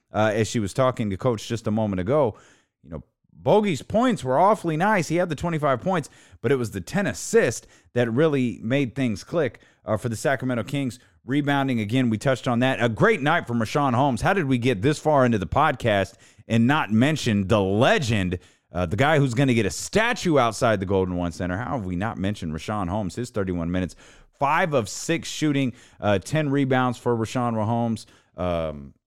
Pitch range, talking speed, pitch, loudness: 105-140 Hz, 205 wpm, 120 Hz, -23 LUFS